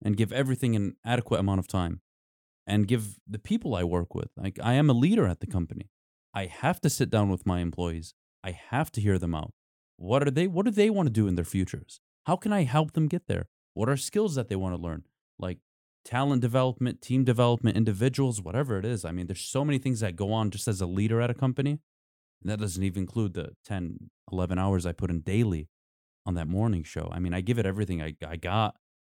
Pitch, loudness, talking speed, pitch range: 105 Hz, -28 LUFS, 240 wpm, 90-125 Hz